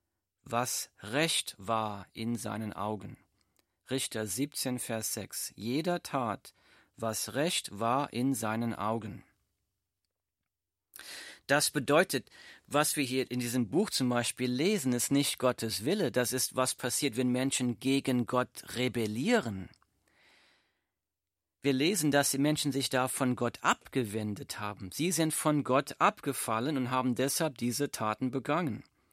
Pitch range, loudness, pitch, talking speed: 110-135 Hz, -31 LUFS, 125 Hz, 130 wpm